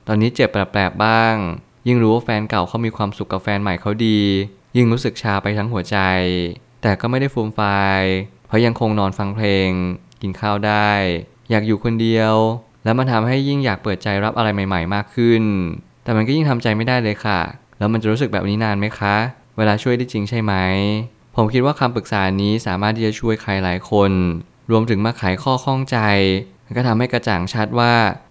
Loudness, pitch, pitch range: -18 LUFS, 110 Hz, 100-115 Hz